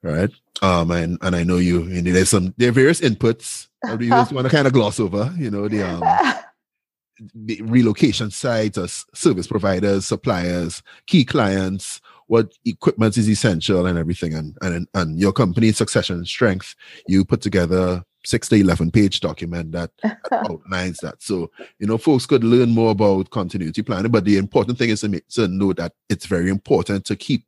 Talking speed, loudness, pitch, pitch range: 185 wpm, -19 LUFS, 100 Hz, 90-115 Hz